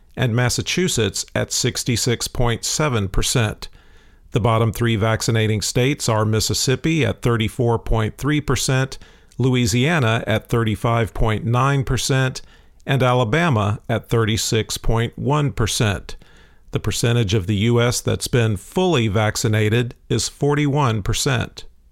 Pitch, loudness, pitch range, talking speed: 115 Hz, -19 LUFS, 110-130 Hz, 85 wpm